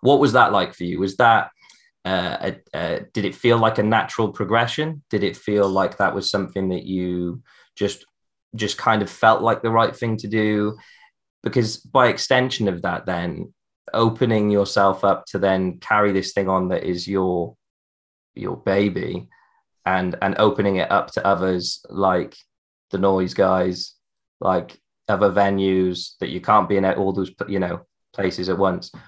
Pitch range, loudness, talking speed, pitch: 95-110 Hz, -21 LUFS, 175 wpm, 100 Hz